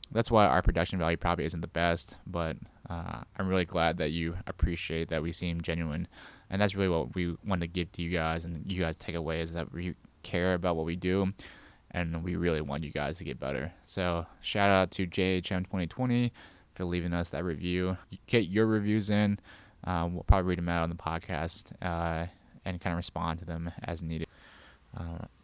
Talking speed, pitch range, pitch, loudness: 210 wpm, 85-95 Hz, 85 Hz, -32 LUFS